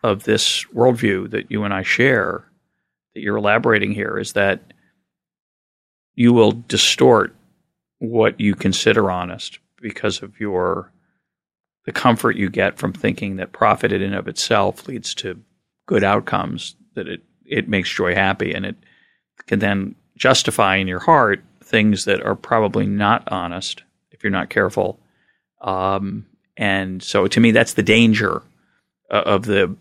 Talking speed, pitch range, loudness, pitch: 155 wpm, 95-110 Hz, -18 LUFS, 100 Hz